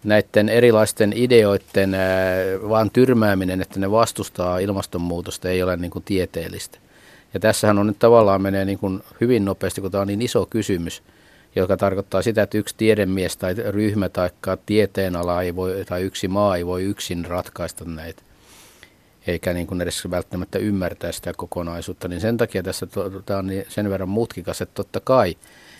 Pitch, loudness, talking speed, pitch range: 95 Hz, -21 LUFS, 170 wpm, 90-105 Hz